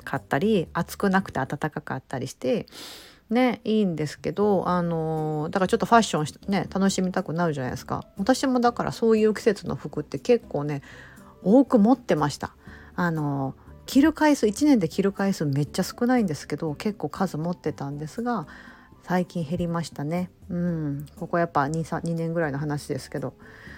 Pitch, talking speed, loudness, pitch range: 175 Hz, 365 characters per minute, -25 LUFS, 150-215 Hz